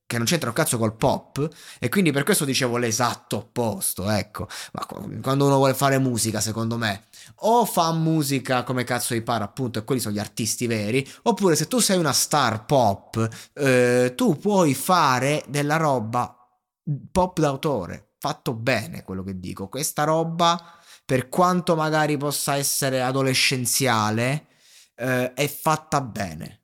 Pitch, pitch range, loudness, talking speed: 130 Hz, 120-155 Hz, -22 LUFS, 155 wpm